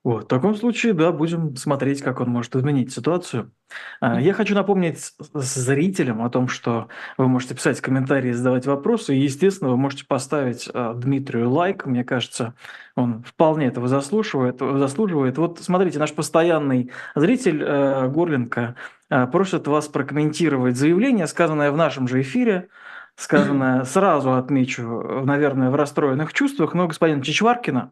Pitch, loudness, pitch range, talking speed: 140 Hz, -21 LUFS, 130-165 Hz, 145 wpm